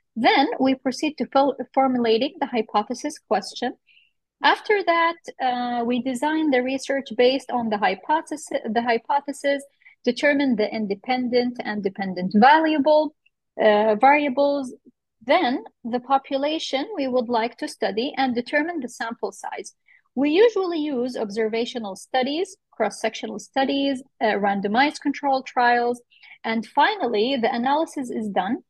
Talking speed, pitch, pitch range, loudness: 125 wpm, 260 Hz, 235-285 Hz, -22 LUFS